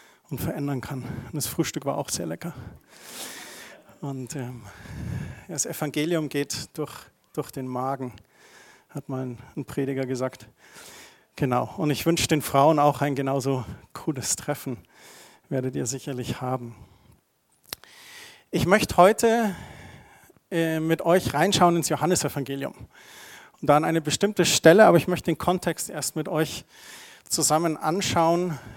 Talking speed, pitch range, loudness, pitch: 130 wpm, 130-165 Hz, -24 LUFS, 145 Hz